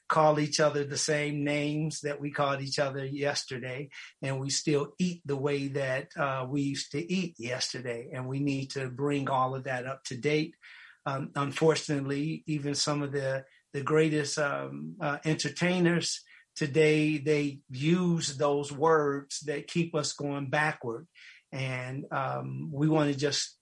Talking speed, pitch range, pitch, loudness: 160 wpm, 135-155 Hz, 145 Hz, -30 LUFS